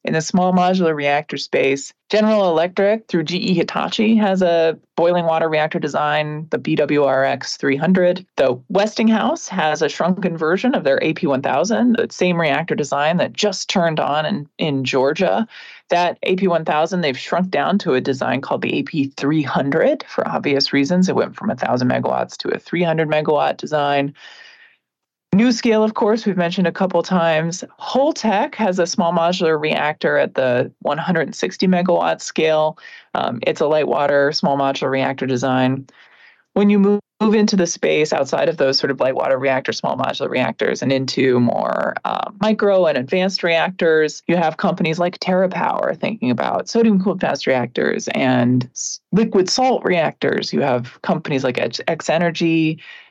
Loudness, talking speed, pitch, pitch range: -18 LUFS, 160 wpm, 170 Hz, 150-200 Hz